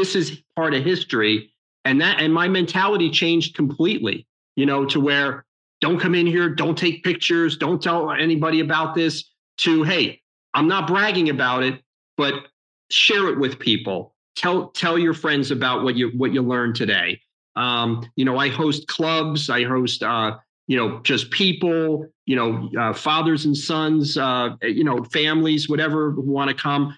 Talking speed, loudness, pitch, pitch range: 175 wpm, -20 LUFS, 155 Hz, 135-165 Hz